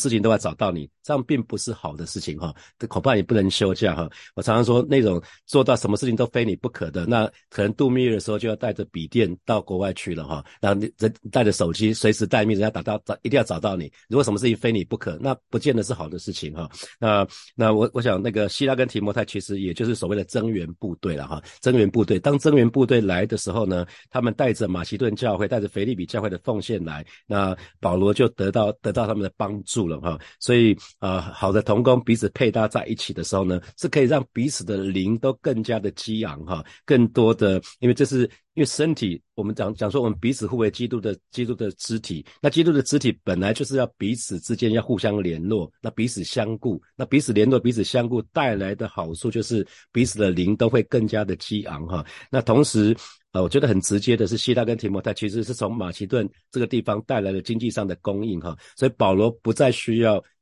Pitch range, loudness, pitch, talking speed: 100-120 Hz, -23 LUFS, 110 Hz, 350 characters per minute